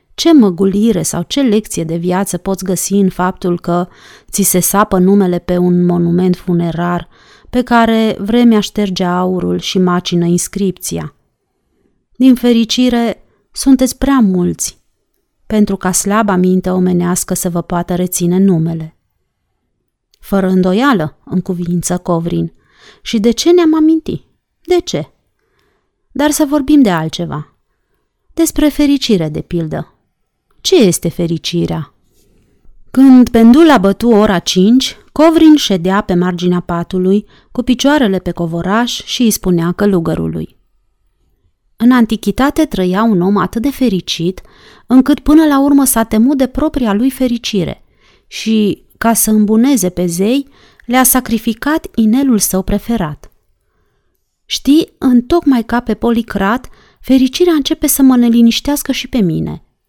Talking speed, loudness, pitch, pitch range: 130 wpm, -12 LUFS, 200 Hz, 180-250 Hz